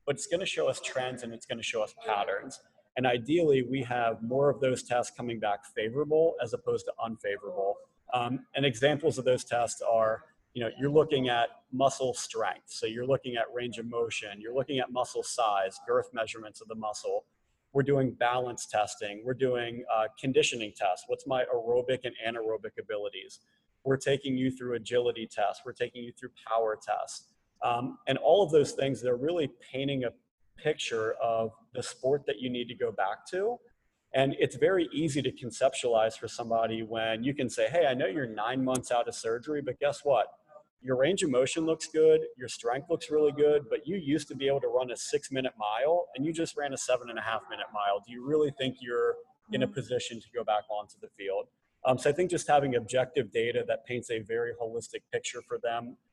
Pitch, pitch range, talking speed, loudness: 130 Hz, 120-165 Hz, 210 wpm, -30 LUFS